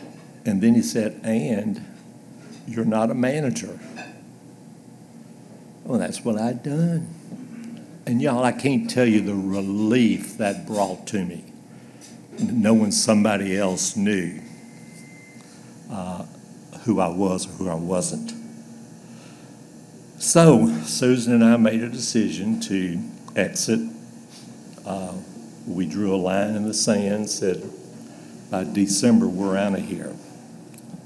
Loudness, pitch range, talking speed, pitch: -22 LUFS, 100-165 Hz, 120 wpm, 110 Hz